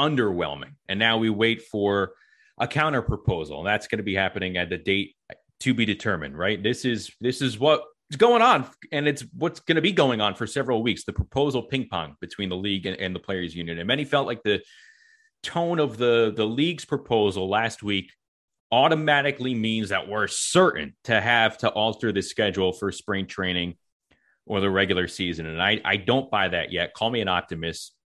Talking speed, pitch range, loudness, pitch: 200 wpm, 95-135 Hz, -24 LUFS, 110 Hz